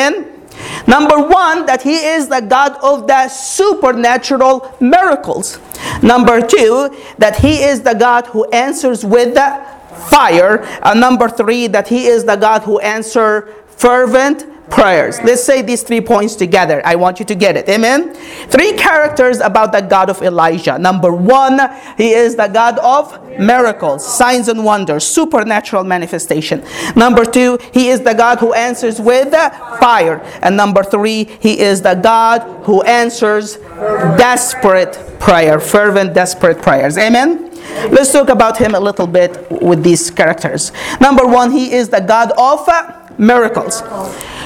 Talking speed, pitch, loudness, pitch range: 155 wpm, 235 Hz, -10 LUFS, 210-265 Hz